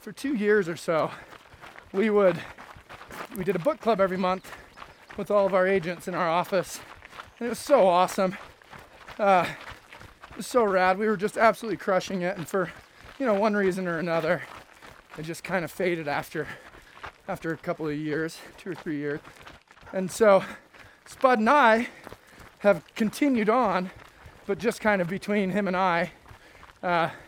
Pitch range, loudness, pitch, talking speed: 175-215 Hz, -25 LUFS, 190 Hz, 170 wpm